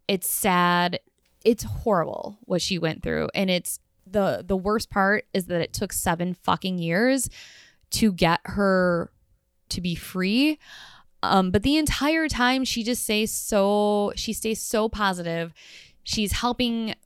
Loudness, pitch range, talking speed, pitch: -24 LUFS, 180-225 Hz, 150 wpm, 200 Hz